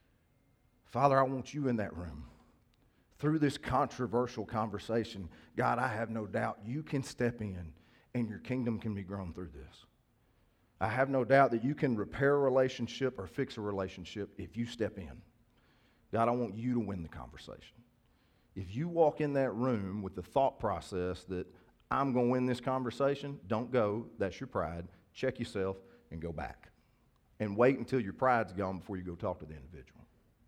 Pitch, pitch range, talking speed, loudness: 115 Hz, 95-125 Hz, 185 wpm, -34 LUFS